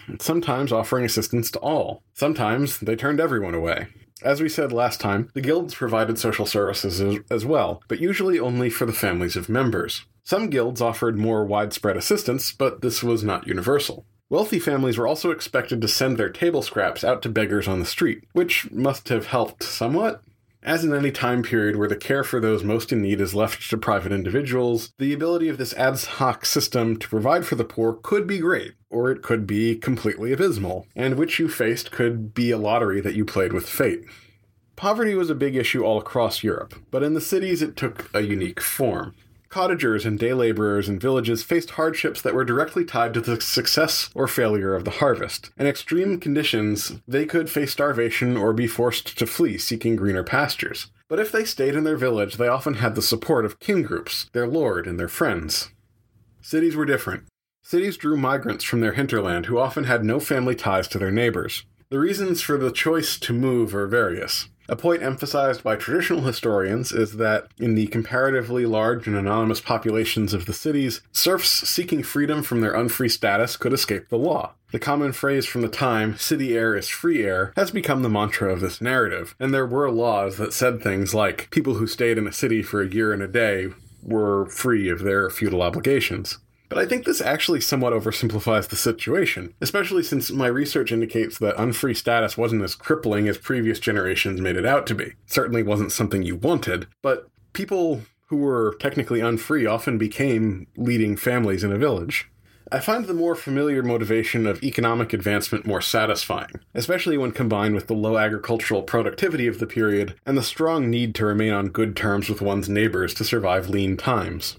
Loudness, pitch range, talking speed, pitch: -23 LUFS, 105-135 Hz, 195 wpm, 115 Hz